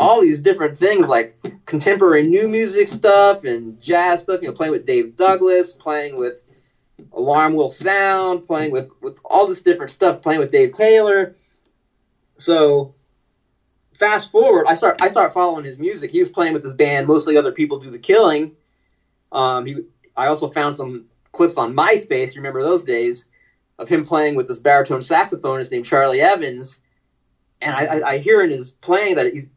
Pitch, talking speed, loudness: 175 Hz, 180 wpm, -16 LUFS